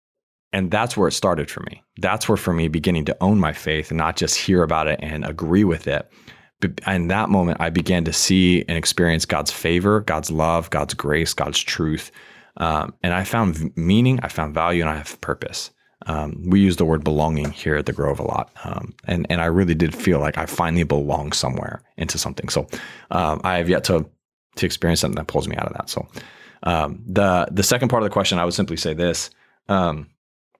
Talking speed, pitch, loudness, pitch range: 215 wpm, 85 Hz, -21 LUFS, 80-90 Hz